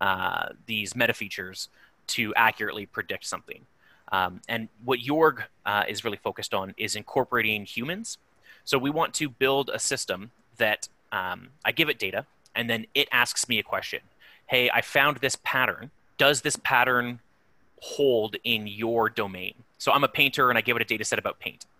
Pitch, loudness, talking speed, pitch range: 120 Hz, -26 LUFS, 180 wpm, 110-140 Hz